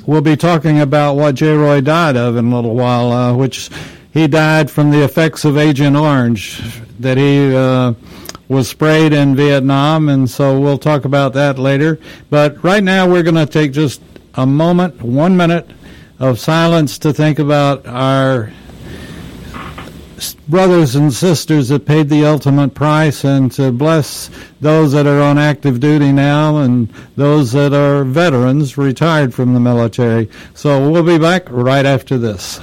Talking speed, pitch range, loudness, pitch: 165 wpm, 130-155 Hz, -12 LUFS, 145 Hz